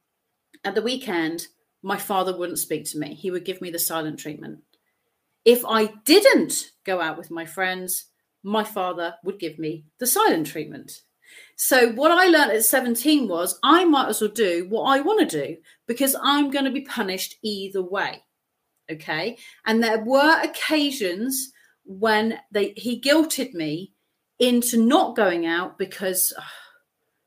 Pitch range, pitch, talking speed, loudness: 180-260 Hz, 215 Hz, 160 wpm, -22 LUFS